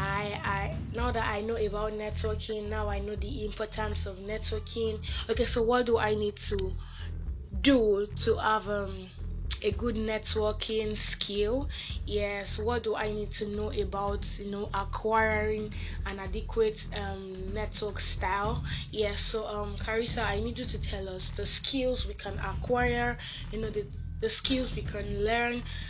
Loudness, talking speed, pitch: -30 LUFS, 160 wpm, 210 Hz